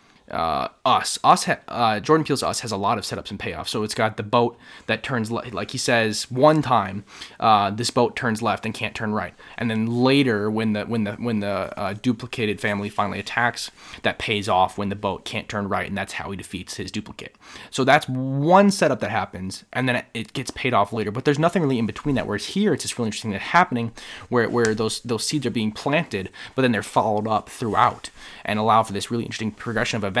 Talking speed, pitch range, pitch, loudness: 235 wpm, 105-125 Hz, 115 Hz, -22 LUFS